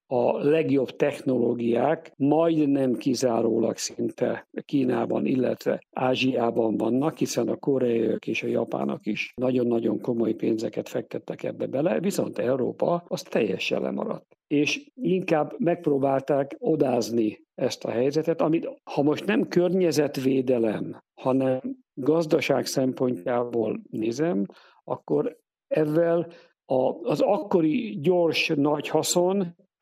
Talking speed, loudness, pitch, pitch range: 105 wpm, -25 LUFS, 140 Hz, 120-160 Hz